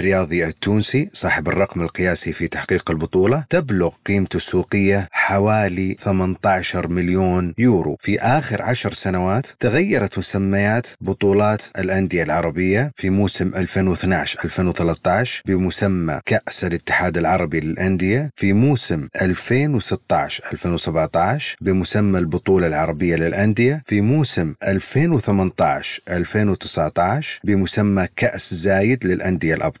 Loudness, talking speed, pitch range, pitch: -19 LUFS, 100 wpm, 90-105 Hz, 95 Hz